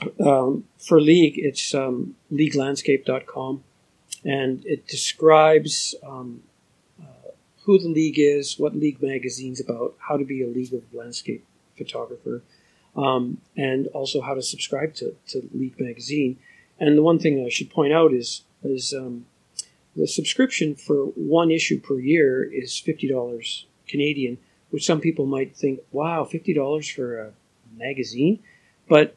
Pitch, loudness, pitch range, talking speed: 140 Hz, -22 LUFS, 130-155 Hz, 145 wpm